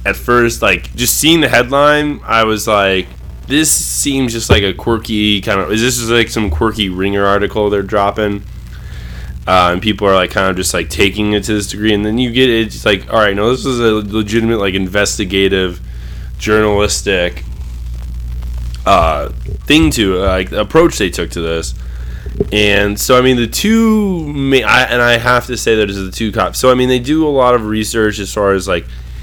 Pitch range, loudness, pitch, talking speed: 95-120 Hz, -12 LUFS, 105 Hz, 205 wpm